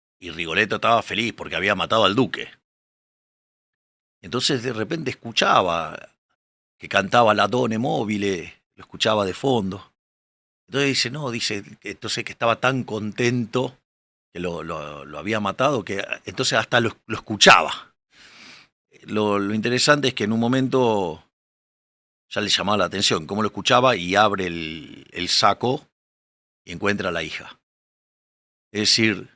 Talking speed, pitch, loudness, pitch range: 145 wpm, 110 Hz, -21 LUFS, 95-125 Hz